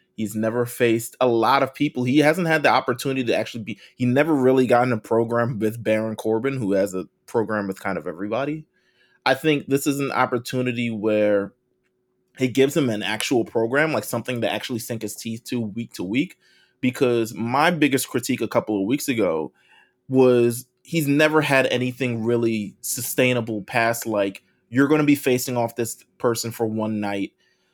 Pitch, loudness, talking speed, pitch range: 120 Hz, -22 LUFS, 185 wpm, 110-130 Hz